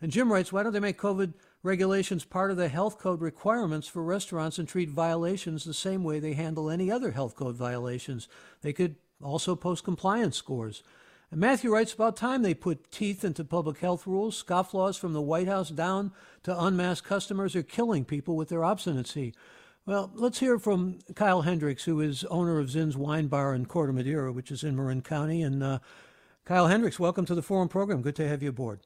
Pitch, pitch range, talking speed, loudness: 175 Hz, 150-195 Hz, 205 wpm, -29 LUFS